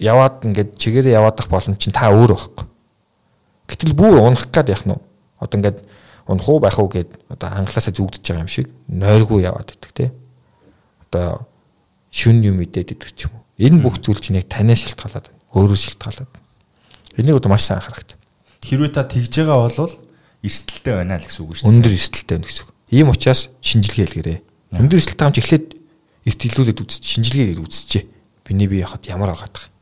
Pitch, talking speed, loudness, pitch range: 110 Hz, 185 wpm, -16 LUFS, 95-125 Hz